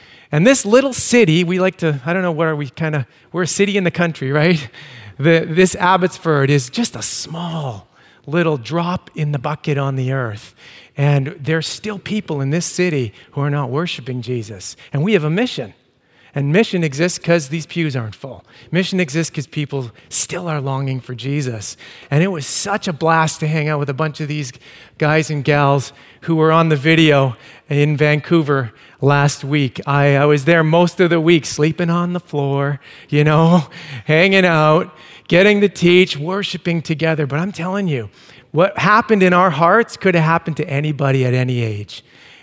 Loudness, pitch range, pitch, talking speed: -16 LUFS, 140-175 Hz, 155 Hz, 190 wpm